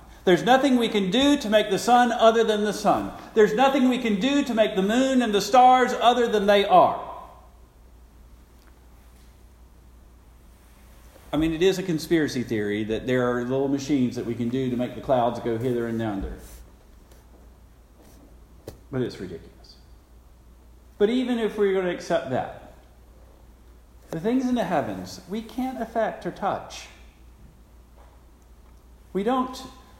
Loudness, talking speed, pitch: -23 LUFS, 155 wpm, 125 Hz